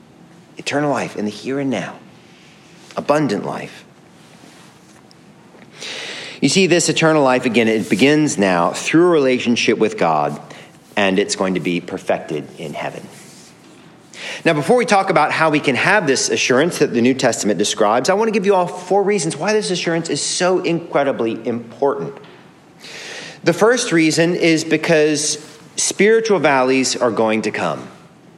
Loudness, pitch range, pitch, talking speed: -16 LUFS, 125-175 Hz, 150 Hz, 155 wpm